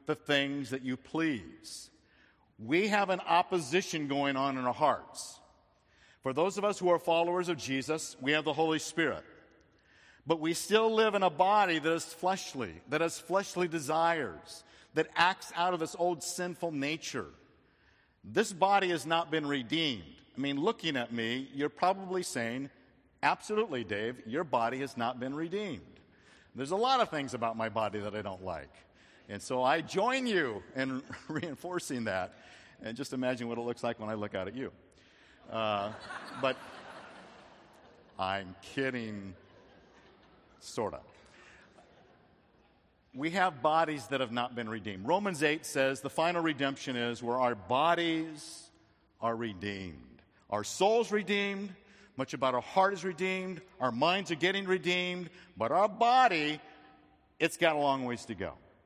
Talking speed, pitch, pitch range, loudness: 160 wpm, 155 Hz, 125-180 Hz, -32 LUFS